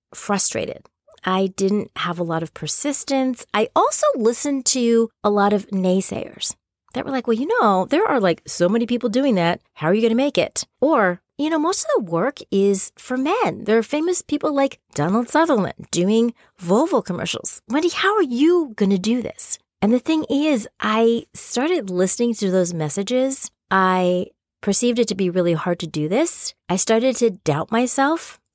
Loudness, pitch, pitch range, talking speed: -20 LUFS, 230 Hz, 190-270 Hz, 190 wpm